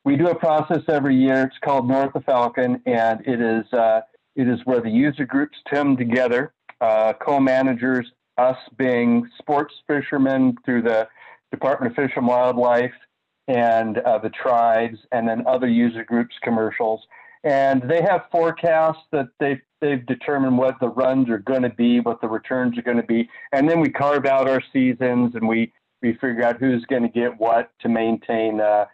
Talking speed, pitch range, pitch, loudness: 185 wpm, 115-140 Hz, 125 Hz, -20 LUFS